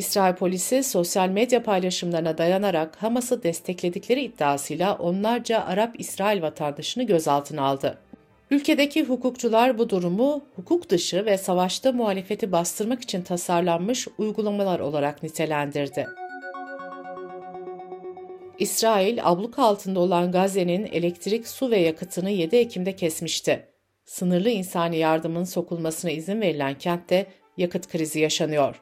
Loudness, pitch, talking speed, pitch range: -24 LUFS, 185 Hz, 110 wpm, 170-220 Hz